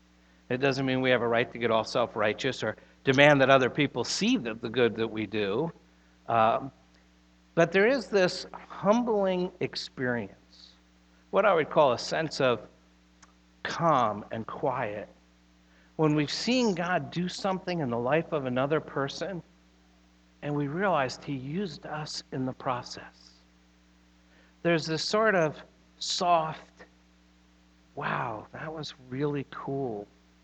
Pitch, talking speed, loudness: 125 Hz, 140 wpm, -28 LUFS